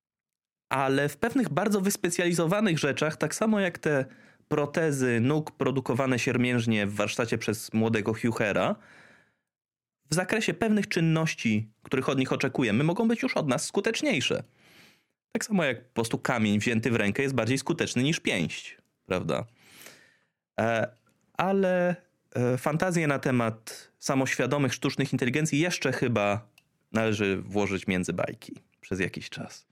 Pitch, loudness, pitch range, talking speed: 140 Hz, -27 LUFS, 120-175 Hz, 130 wpm